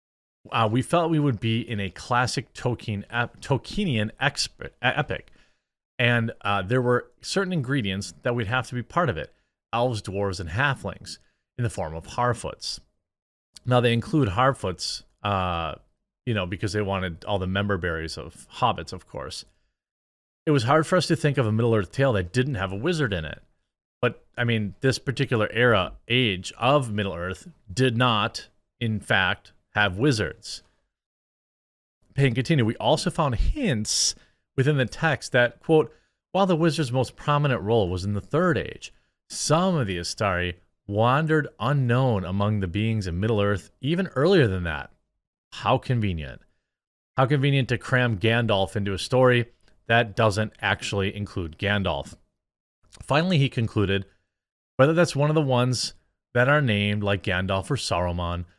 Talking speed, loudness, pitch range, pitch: 160 wpm, -24 LUFS, 100-135 Hz, 115 Hz